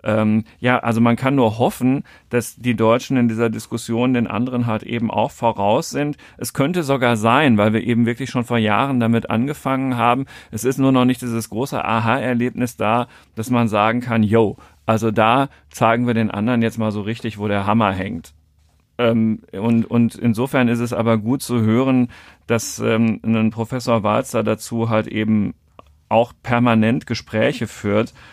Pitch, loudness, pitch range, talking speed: 115 Hz, -19 LUFS, 110-125 Hz, 180 wpm